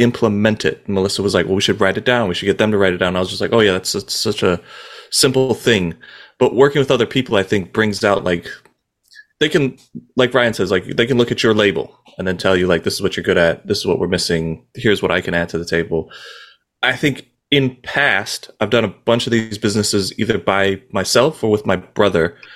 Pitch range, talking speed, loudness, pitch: 90-115 Hz, 260 wpm, -17 LUFS, 100 Hz